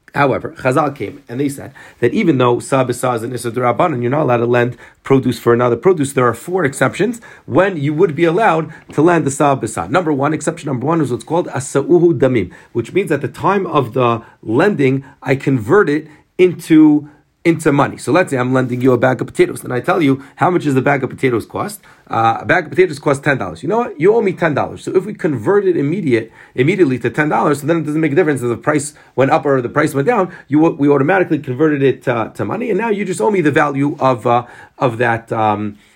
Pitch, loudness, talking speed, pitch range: 140 Hz, -15 LUFS, 240 wpm, 125-165 Hz